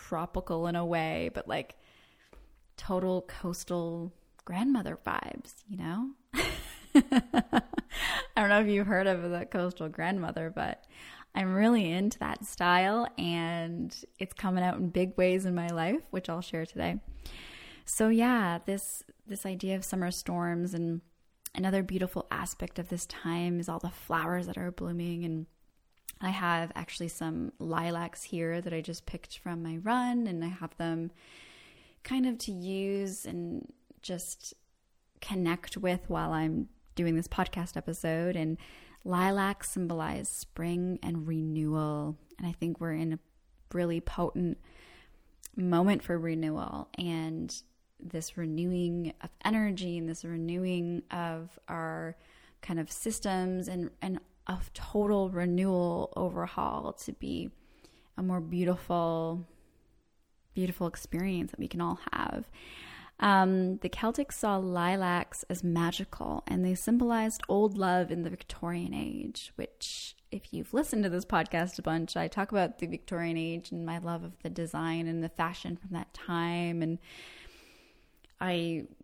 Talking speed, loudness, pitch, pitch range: 145 wpm, -33 LUFS, 175 Hz, 165-190 Hz